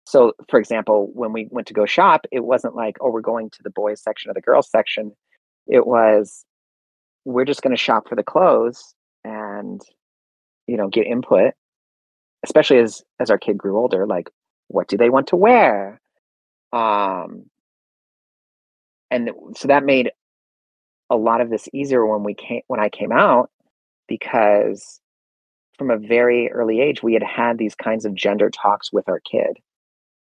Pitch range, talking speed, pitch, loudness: 105-120 Hz, 170 wpm, 110 Hz, -18 LUFS